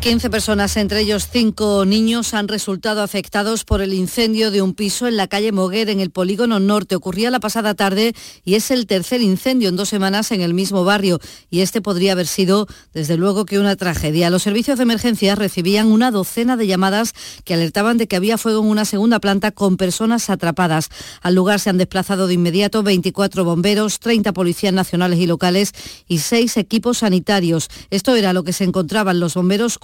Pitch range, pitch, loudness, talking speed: 185-220 Hz, 200 Hz, -17 LUFS, 195 wpm